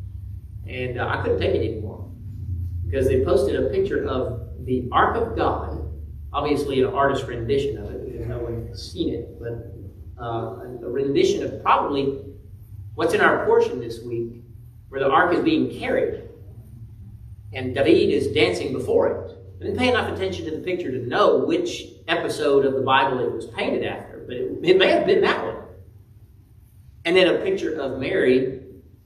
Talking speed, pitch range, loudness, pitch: 175 wpm, 100-140 Hz, -22 LUFS, 115 Hz